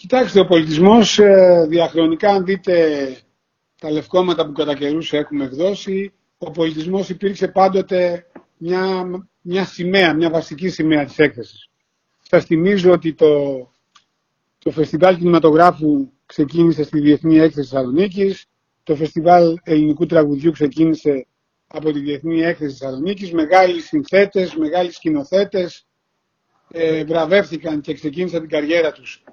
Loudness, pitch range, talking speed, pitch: -16 LUFS, 155-185 Hz, 120 wpm, 165 Hz